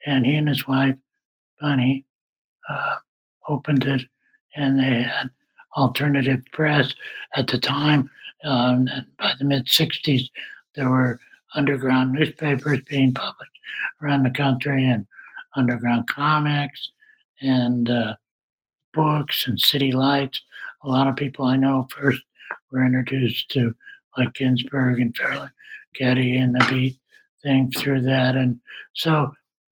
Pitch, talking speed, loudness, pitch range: 135 Hz, 130 wpm, -22 LUFS, 130-145 Hz